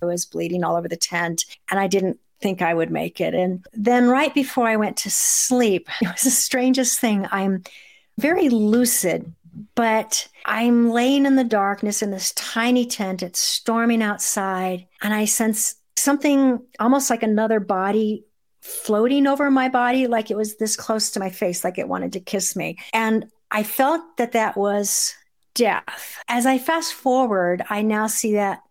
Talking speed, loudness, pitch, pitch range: 180 wpm, -20 LUFS, 220 Hz, 195-245 Hz